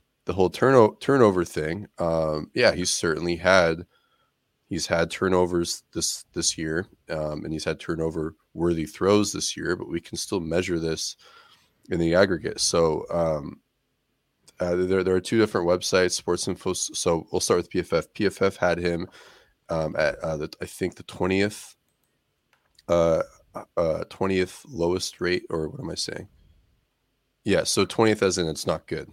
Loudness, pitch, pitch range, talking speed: -25 LUFS, 85 Hz, 80-90 Hz, 165 wpm